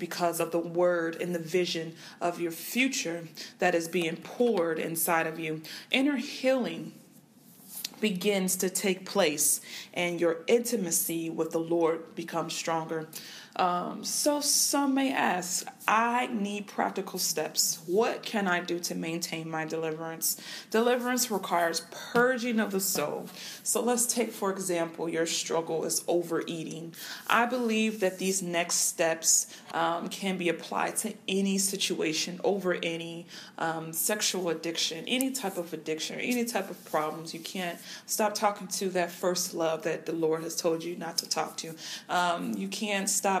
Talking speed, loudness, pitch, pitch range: 155 wpm, -29 LUFS, 175 Hz, 165-210 Hz